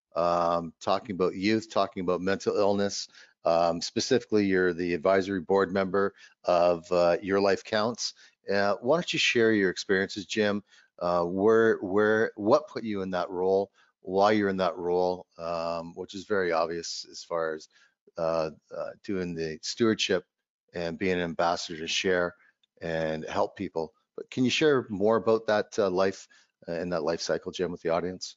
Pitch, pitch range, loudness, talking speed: 95 Hz, 85-100 Hz, -27 LUFS, 170 wpm